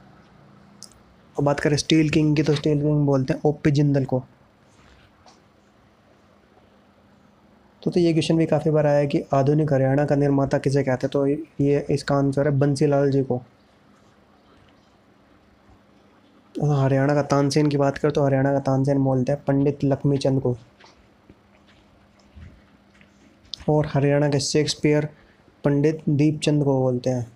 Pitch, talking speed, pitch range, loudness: 140 Hz, 140 wpm, 135-150 Hz, -21 LUFS